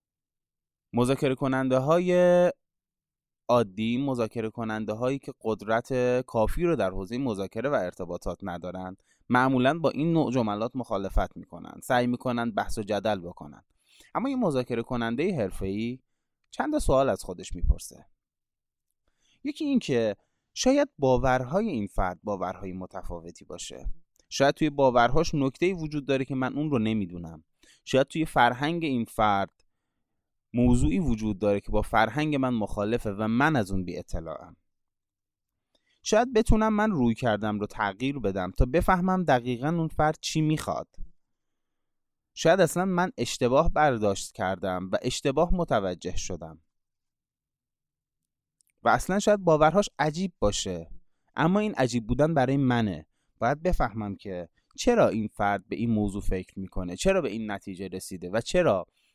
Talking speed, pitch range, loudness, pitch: 140 wpm, 100-150 Hz, -27 LUFS, 120 Hz